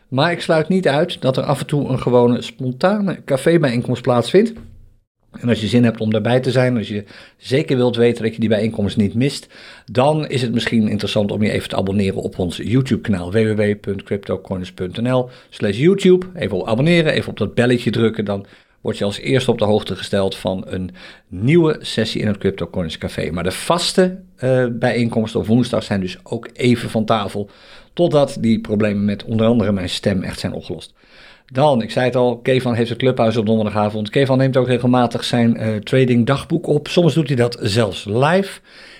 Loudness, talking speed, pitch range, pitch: -18 LUFS, 195 wpm, 105-130 Hz, 120 Hz